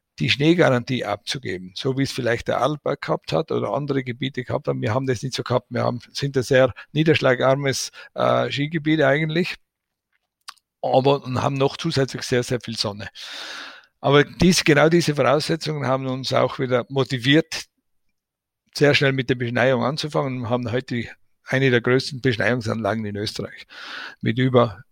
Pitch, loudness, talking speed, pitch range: 130 Hz, -21 LUFS, 160 wpm, 120-140 Hz